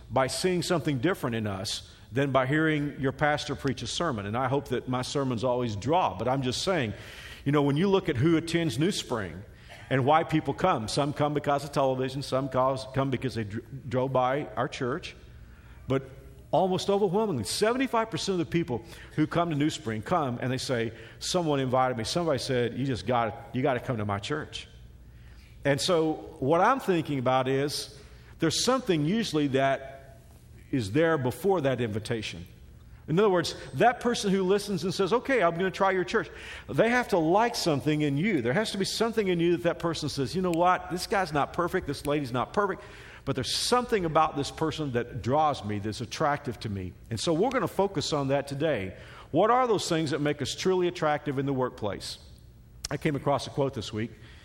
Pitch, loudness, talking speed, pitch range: 145 Hz, -28 LUFS, 205 wpm, 125-170 Hz